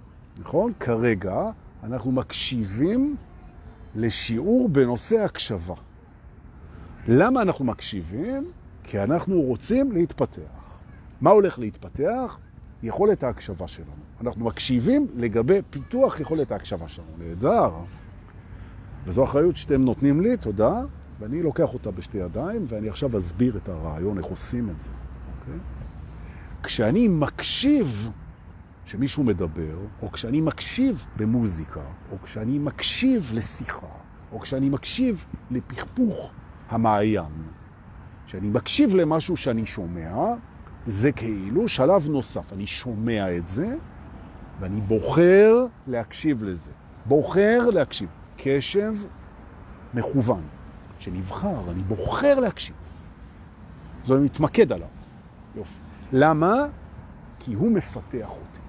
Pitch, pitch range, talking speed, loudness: 110 Hz, 90-145 Hz, 100 wpm, -24 LUFS